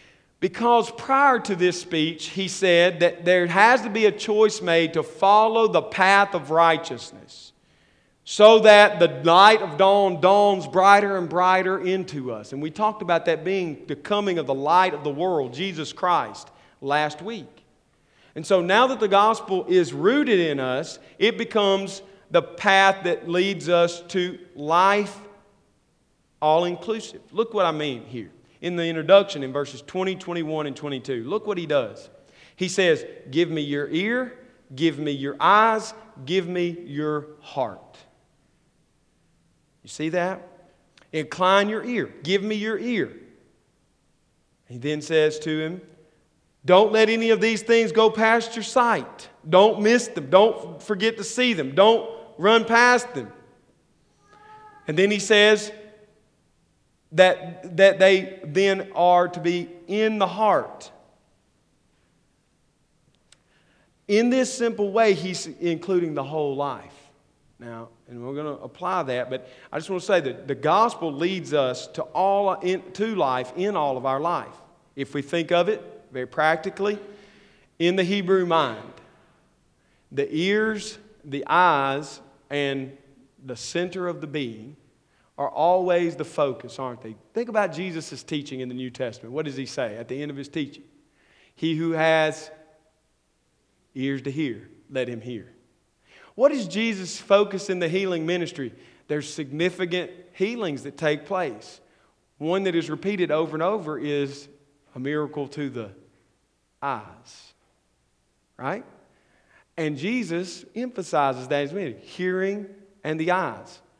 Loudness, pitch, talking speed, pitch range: -22 LUFS, 175 Hz, 150 wpm, 150-200 Hz